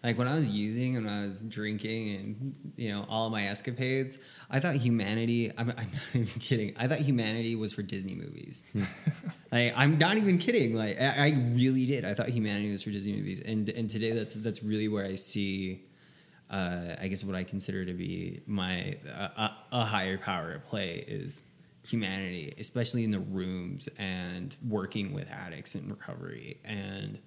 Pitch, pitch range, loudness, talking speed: 110 Hz, 100-125 Hz, -31 LUFS, 185 wpm